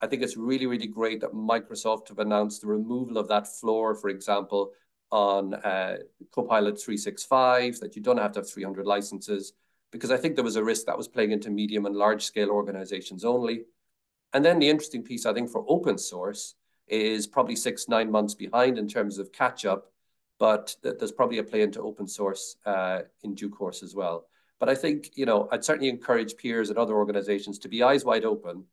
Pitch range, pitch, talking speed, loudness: 100-115 Hz, 105 Hz, 215 wpm, -27 LUFS